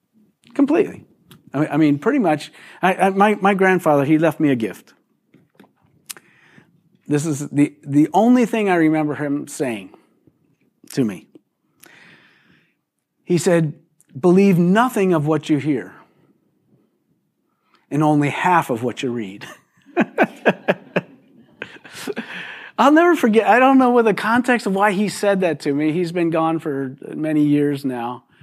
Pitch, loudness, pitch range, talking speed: 160 Hz, -18 LUFS, 145-200 Hz, 135 wpm